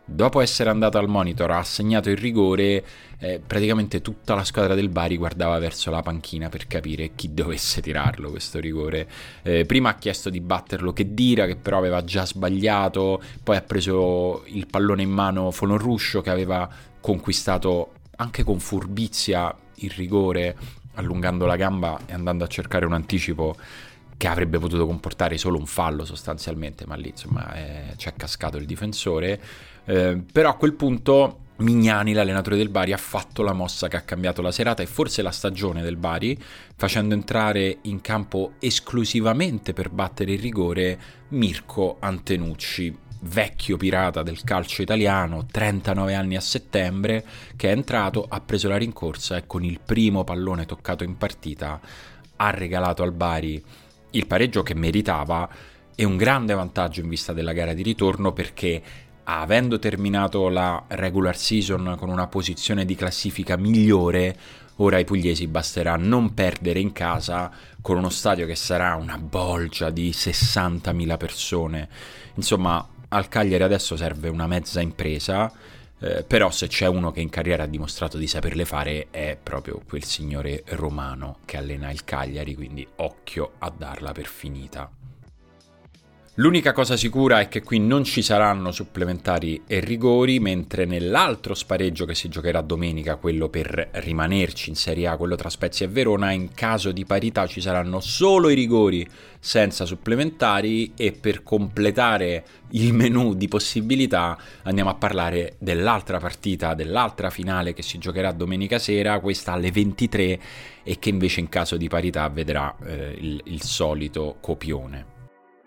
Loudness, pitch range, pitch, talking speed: -23 LUFS, 85-105 Hz, 95 Hz, 155 wpm